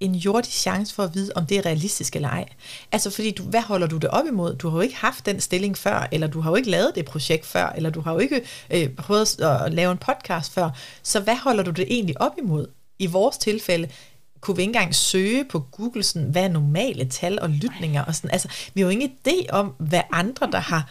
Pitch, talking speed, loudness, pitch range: 180 Hz, 255 wpm, -23 LUFS, 160-205 Hz